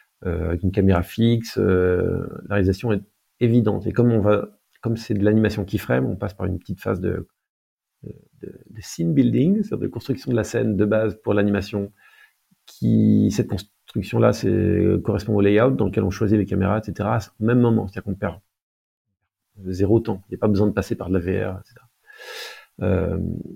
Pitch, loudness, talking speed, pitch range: 105 Hz, -21 LUFS, 195 wpm, 95-115 Hz